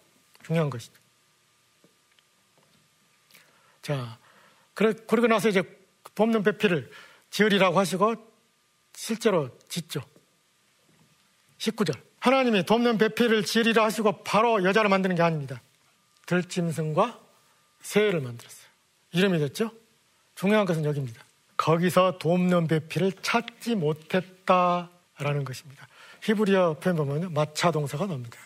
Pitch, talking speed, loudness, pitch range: 180 Hz, 265 characters per minute, -25 LUFS, 150-215 Hz